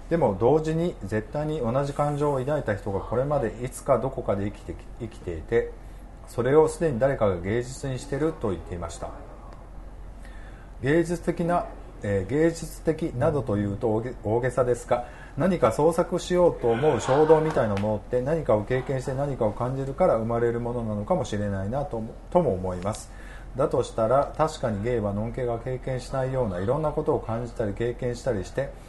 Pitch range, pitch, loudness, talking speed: 110-150 Hz, 125 Hz, -26 LUFS, 380 characters per minute